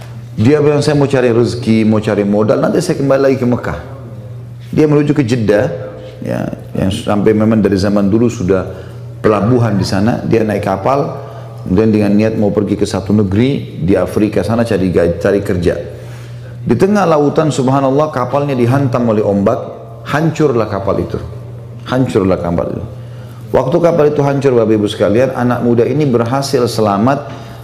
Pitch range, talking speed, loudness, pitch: 105-135 Hz, 160 wpm, -13 LUFS, 120 Hz